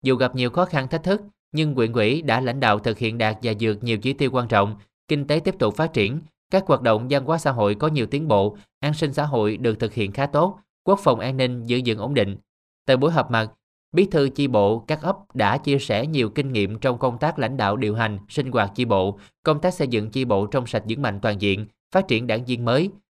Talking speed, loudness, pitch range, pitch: 260 wpm, -22 LUFS, 110-150 Hz, 125 Hz